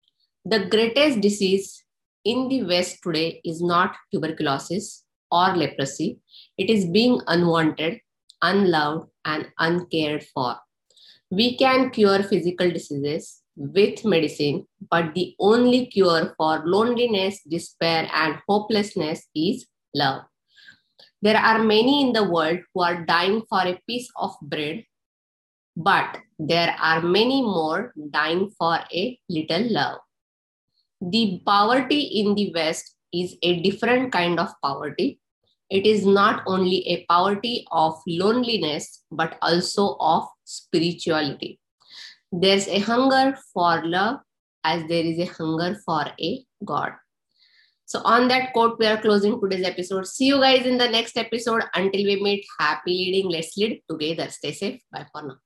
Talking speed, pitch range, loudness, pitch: 135 wpm, 165-215 Hz, -22 LUFS, 185 Hz